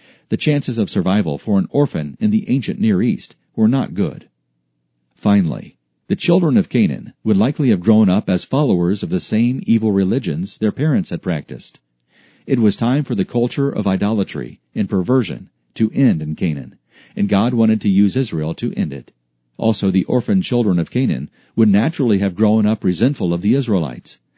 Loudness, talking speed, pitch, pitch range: -17 LUFS, 180 wpm, 105 Hz, 90-125 Hz